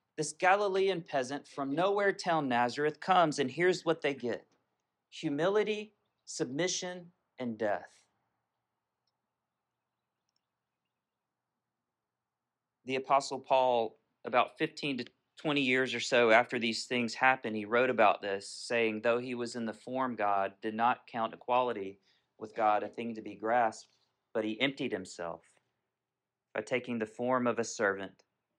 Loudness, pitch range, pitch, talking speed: -32 LUFS, 115-150 Hz, 125 Hz, 135 wpm